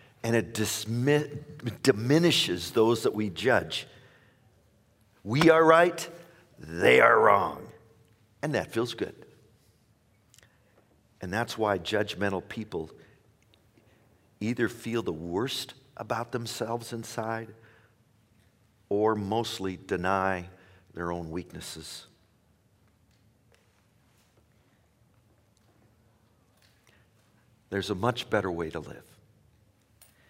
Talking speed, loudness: 85 wpm, -27 LUFS